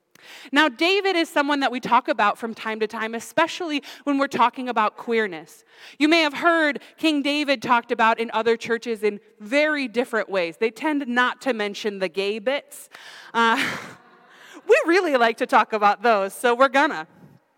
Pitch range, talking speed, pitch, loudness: 220-295 Hz, 175 wpm, 245 Hz, -21 LUFS